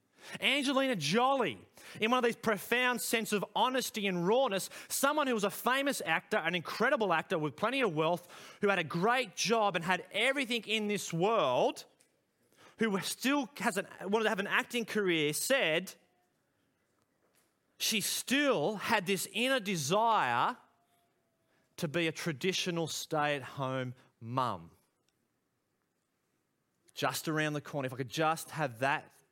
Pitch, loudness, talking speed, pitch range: 200 Hz, -32 LUFS, 140 wpm, 160-235 Hz